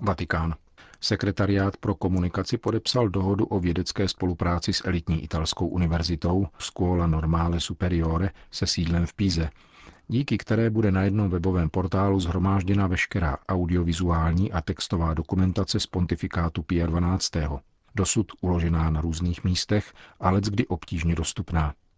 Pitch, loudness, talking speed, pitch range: 90 Hz, -26 LUFS, 125 wpm, 85-100 Hz